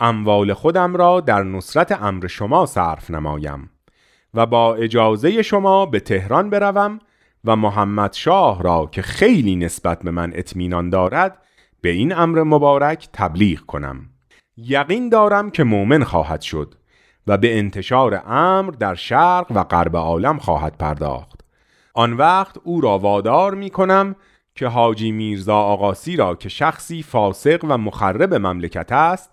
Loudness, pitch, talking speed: -17 LUFS, 110 Hz, 140 wpm